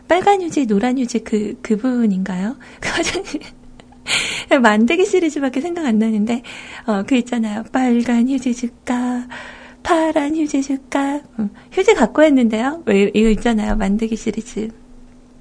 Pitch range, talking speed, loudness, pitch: 220-285 Hz, 275 characters per minute, -18 LUFS, 245 Hz